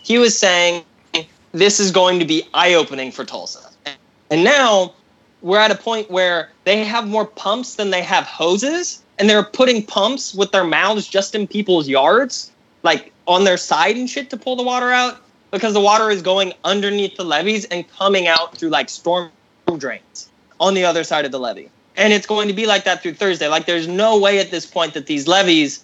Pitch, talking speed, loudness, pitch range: 195 Hz, 210 wpm, -16 LUFS, 175-215 Hz